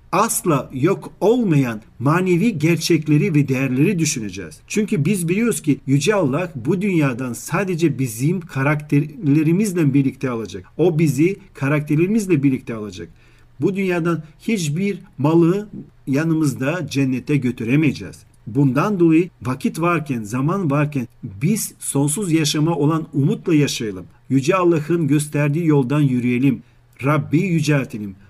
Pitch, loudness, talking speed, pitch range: 150 Hz, -19 LUFS, 110 wpm, 130-170 Hz